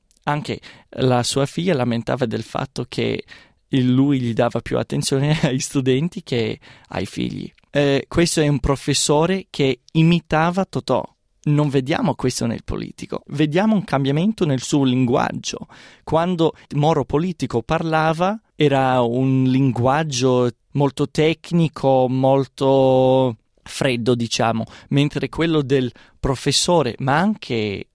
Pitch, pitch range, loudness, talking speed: 140 Hz, 130-155 Hz, -20 LUFS, 120 wpm